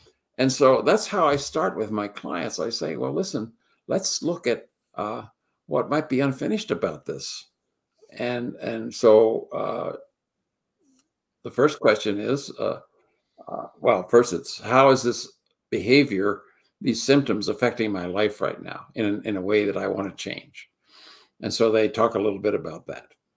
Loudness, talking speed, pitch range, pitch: -23 LUFS, 165 wpm, 105-140 Hz, 120 Hz